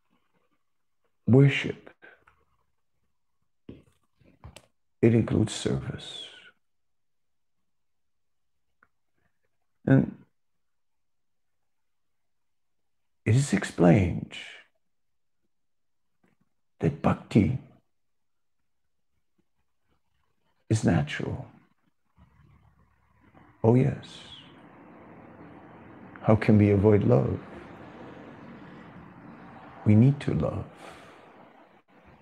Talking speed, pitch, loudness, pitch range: 45 wpm, 105 Hz, -25 LUFS, 90-120 Hz